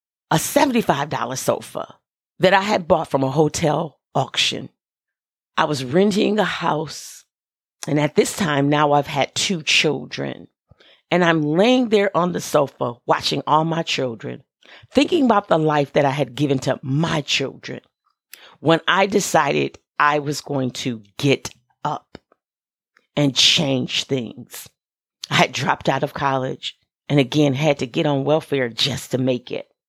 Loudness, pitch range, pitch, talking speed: -19 LUFS, 135-170 Hz, 150 Hz, 155 wpm